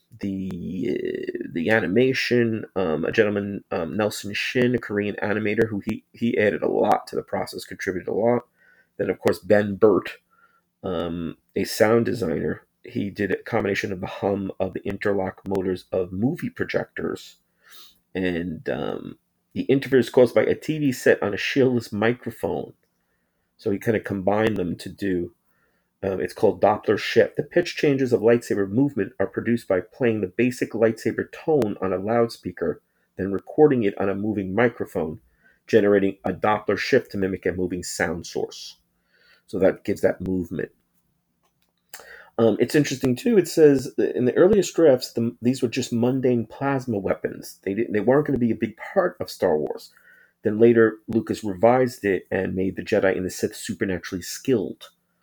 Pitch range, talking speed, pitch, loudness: 100-125 Hz, 170 wpm, 115 Hz, -23 LUFS